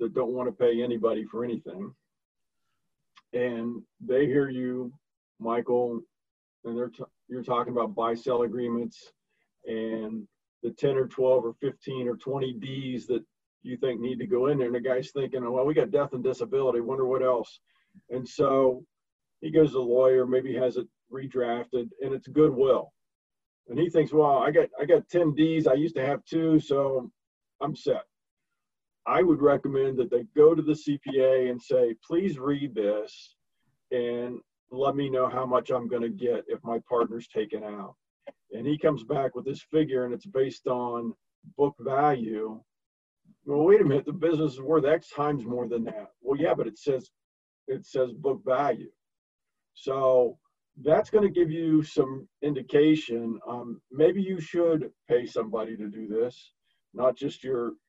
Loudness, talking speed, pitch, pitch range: -27 LUFS, 175 wpm, 130 Hz, 120-150 Hz